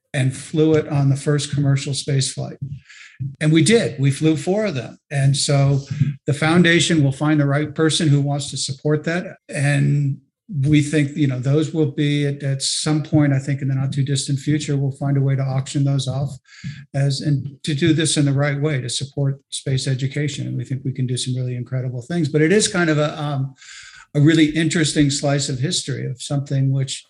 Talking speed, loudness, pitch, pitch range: 215 wpm, -19 LUFS, 140 Hz, 135-150 Hz